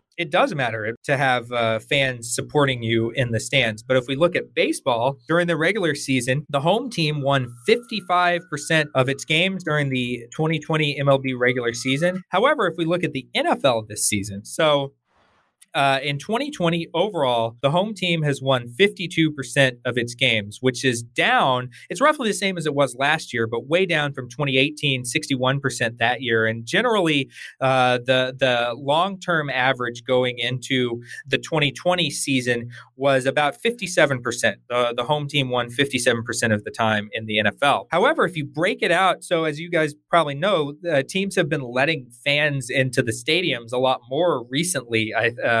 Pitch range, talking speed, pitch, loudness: 125-160 Hz, 175 wpm, 135 Hz, -21 LUFS